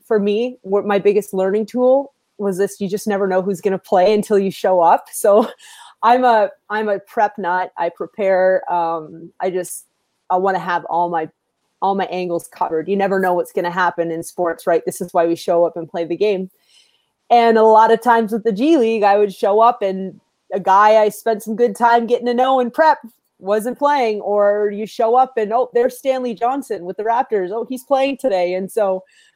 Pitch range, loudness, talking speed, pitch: 185-235 Hz, -17 LUFS, 225 wpm, 205 Hz